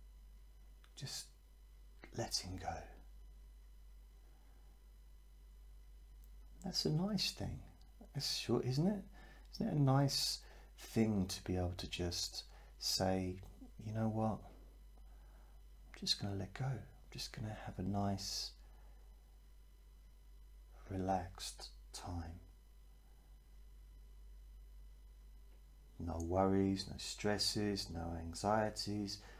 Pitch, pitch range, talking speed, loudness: 70 Hz, 65-100 Hz, 90 wpm, -40 LUFS